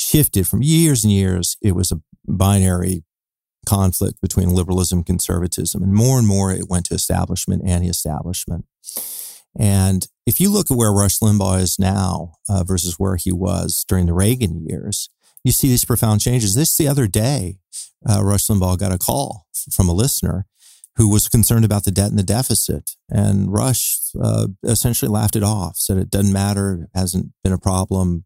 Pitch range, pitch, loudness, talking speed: 90-110 Hz, 100 Hz, -18 LUFS, 180 wpm